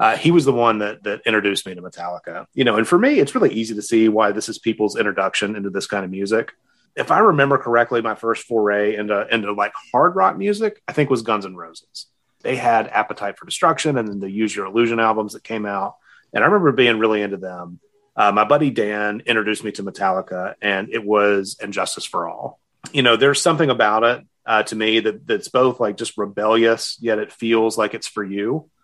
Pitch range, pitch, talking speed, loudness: 105-120 Hz, 110 Hz, 225 wpm, -19 LUFS